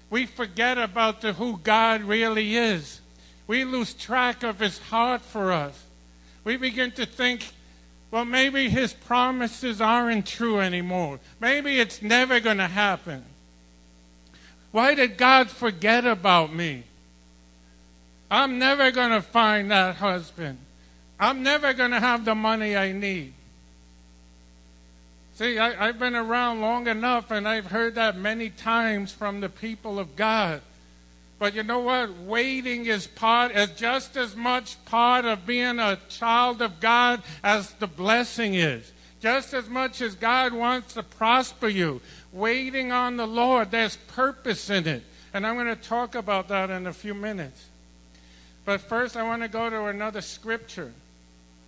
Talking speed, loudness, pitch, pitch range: 155 wpm, -24 LUFS, 220 Hz, 170-240 Hz